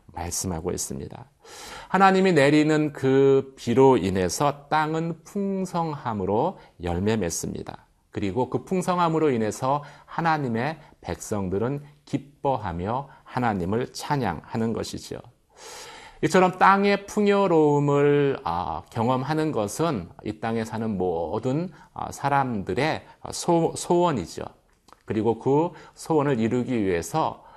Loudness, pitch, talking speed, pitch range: -24 LUFS, 145 Hz, 245 characters per minute, 115-170 Hz